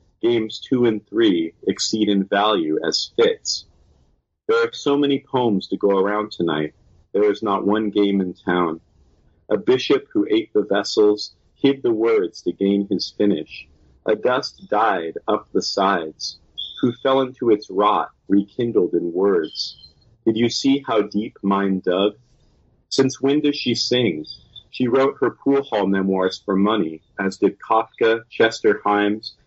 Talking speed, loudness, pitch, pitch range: 155 wpm, -20 LUFS, 110 Hz, 95-140 Hz